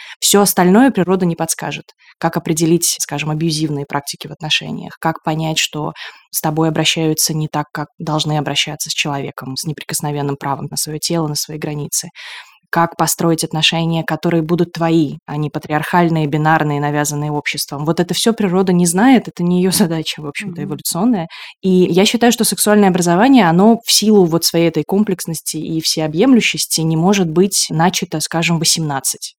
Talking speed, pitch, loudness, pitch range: 165 wpm, 165 Hz, -15 LUFS, 155-180 Hz